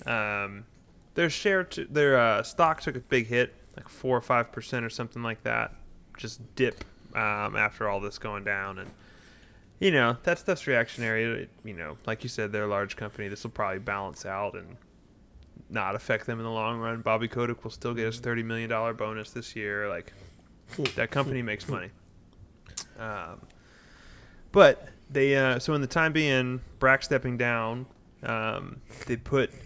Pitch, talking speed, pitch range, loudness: 115 Hz, 180 wpm, 105-130 Hz, -28 LUFS